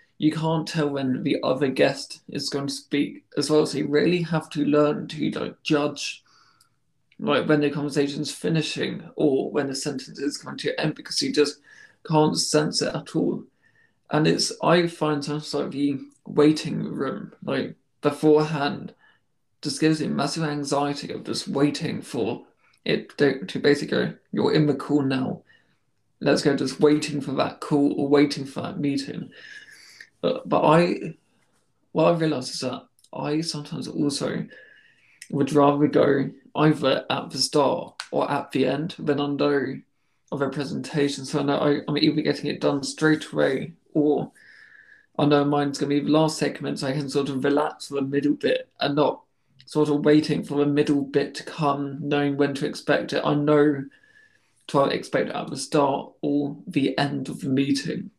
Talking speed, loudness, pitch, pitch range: 175 wpm, -24 LUFS, 145 Hz, 140-155 Hz